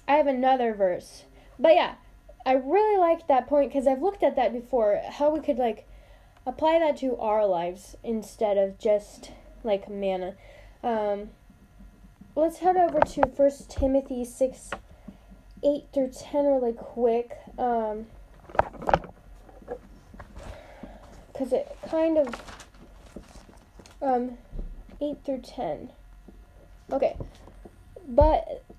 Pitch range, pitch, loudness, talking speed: 235-295 Hz, 270 Hz, -26 LUFS, 115 wpm